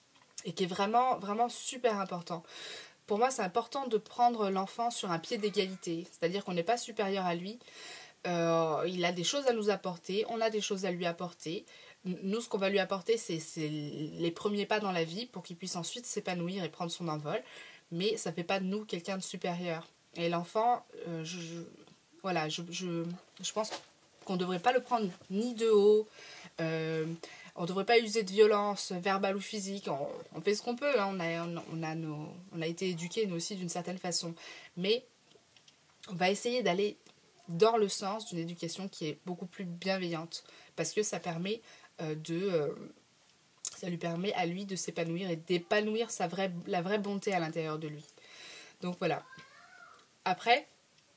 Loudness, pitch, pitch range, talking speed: -34 LUFS, 185 Hz, 170-210 Hz, 195 wpm